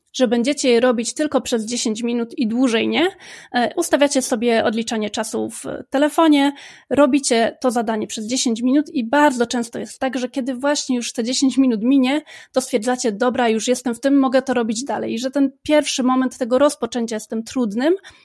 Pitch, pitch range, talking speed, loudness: 255 Hz, 235-280 Hz, 185 wpm, -19 LUFS